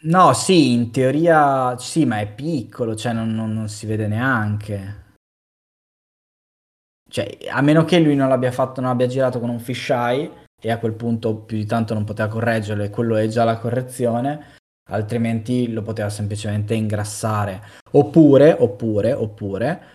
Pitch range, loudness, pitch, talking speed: 110-130 Hz, -19 LUFS, 115 Hz, 160 wpm